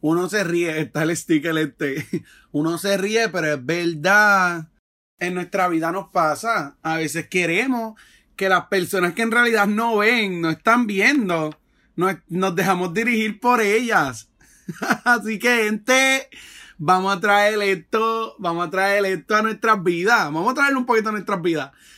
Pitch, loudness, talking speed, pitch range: 195 Hz, -20 LUFS, 165 wpm, 170-220 Hz